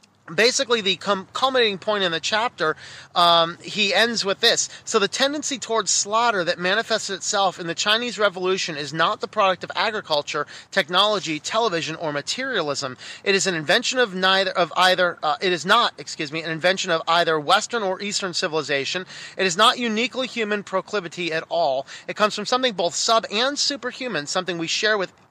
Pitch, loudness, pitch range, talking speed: 190 Hz, -21 LUFS, 170-225 Hz, 185 wpm